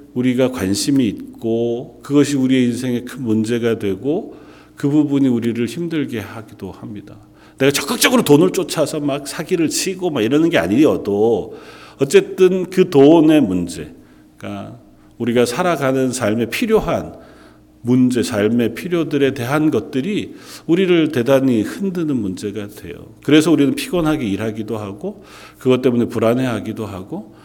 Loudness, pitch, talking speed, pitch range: -17 LUFS, 130 Hz, 320 characters per minute, 110-155 Hz